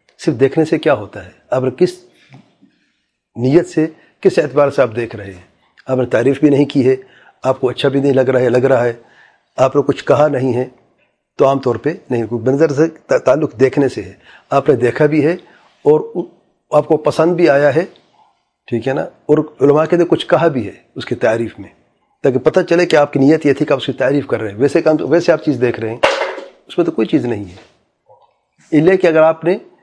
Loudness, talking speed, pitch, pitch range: -14 LUFS, 235 wpm, 140 Hz, 125-160 Hz